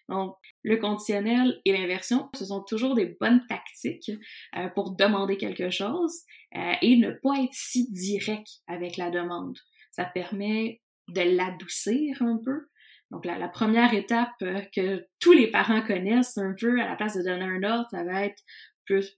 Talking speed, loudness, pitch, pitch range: 165 wpm, -26 LUFS, 210 Hz, 190-240 Hz